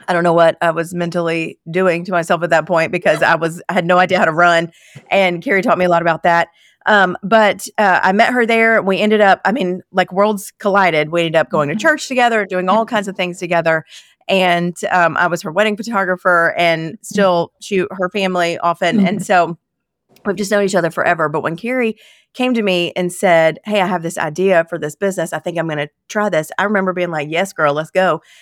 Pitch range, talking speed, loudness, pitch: 170-200 Hz, 235 wpm, -15 LUFS, 180 Hz